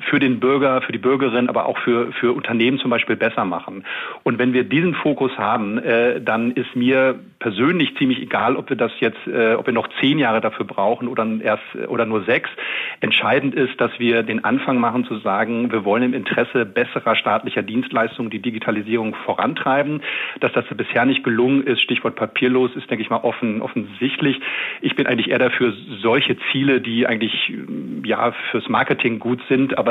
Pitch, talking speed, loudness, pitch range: 125 Hz, 185 wpm, -19 LUFS, 115-130 Hz